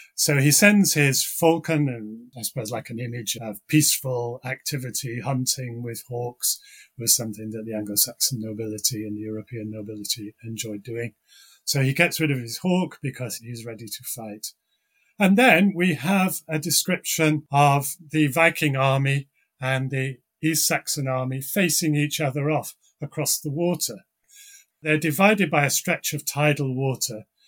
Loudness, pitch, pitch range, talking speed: -23 LUFS, 140 Hz, 120-160 Hz, 155 wpm